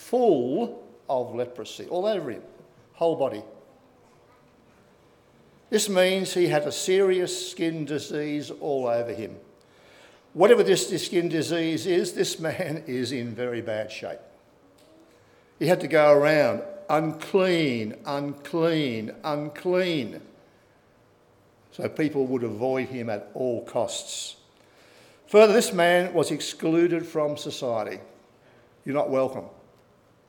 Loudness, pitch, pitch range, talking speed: -25 LUFS, 155 Hz, 130-180 Hz, 115 wpm